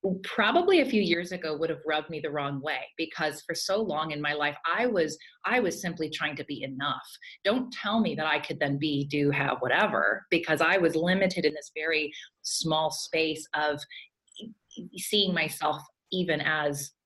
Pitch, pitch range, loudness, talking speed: 155 Hz, 150-175 Hz, -28 LUFS, 185 wpm